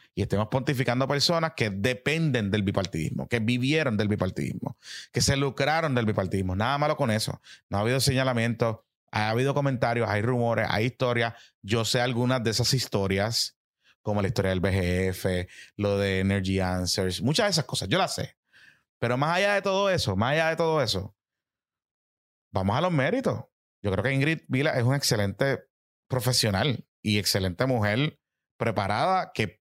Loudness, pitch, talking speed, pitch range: -26 LUFS, 120 Hz, 170 wpm, 100-135 Hz